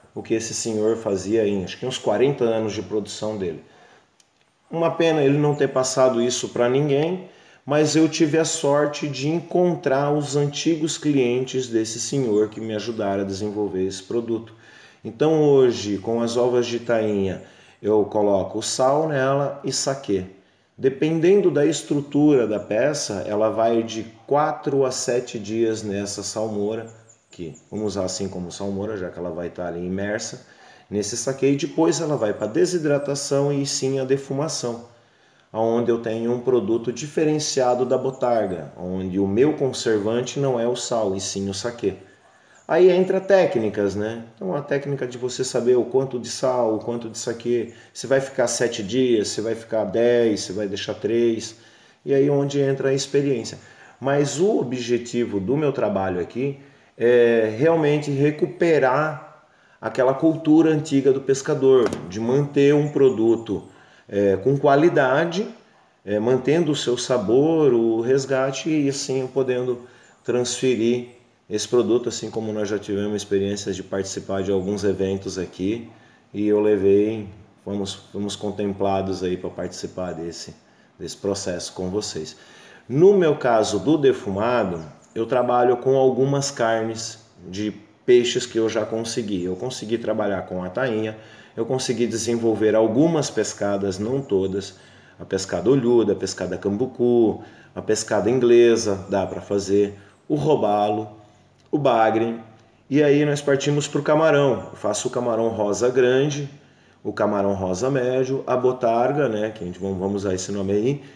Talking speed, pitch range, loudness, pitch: 155 wpm, 105-135 Hz, -22 LUFS, 120 Hz